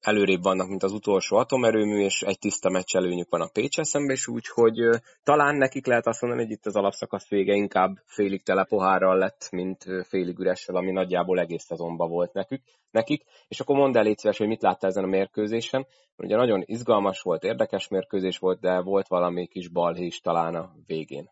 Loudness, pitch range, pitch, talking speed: -25 LUFS, 90-115 Hz, 95 Hz, 195 wpm